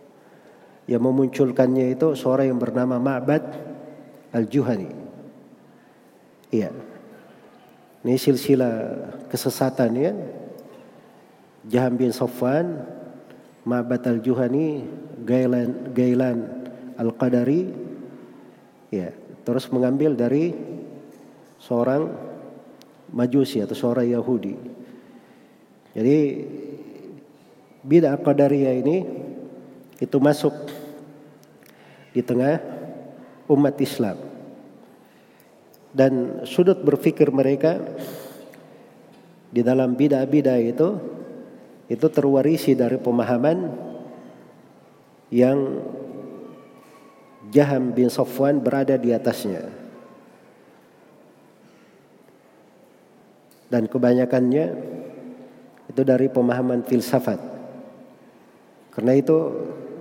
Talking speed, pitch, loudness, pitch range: 65 wpm, 130 Hz, -21 LUFS, 125-145 Hz